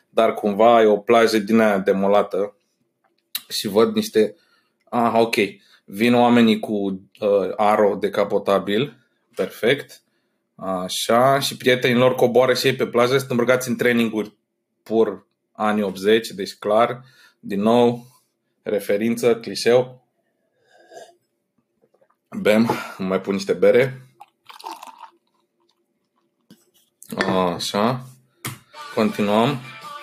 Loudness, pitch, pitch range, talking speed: -19 LUFS, 115 Hz, 105-125 Hz, 100 wpm